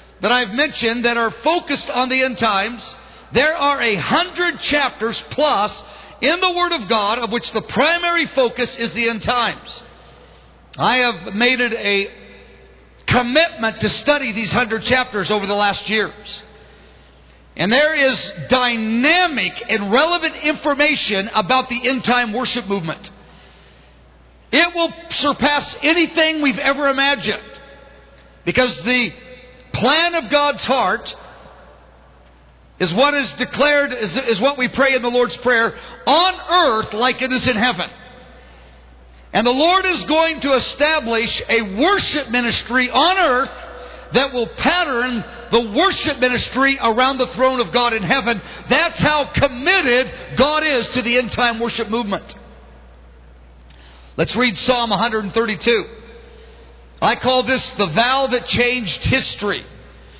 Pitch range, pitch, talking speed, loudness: 215-280 Hz, 245 Hz, 140 wpm, -16 LUFS